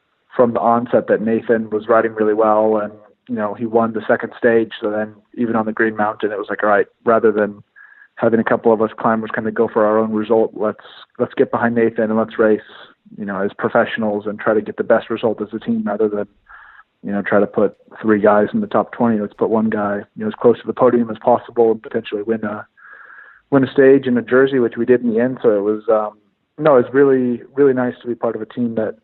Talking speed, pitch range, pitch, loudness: 260 wpm, 110-120 Hz, 115 Hz, -17 LUFS